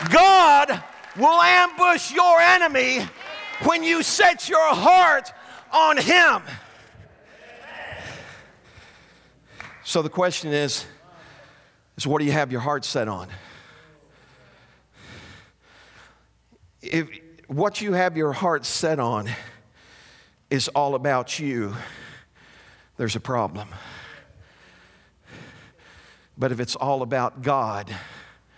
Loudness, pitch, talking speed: -20 LUFS, 155 Hz, 95 wpm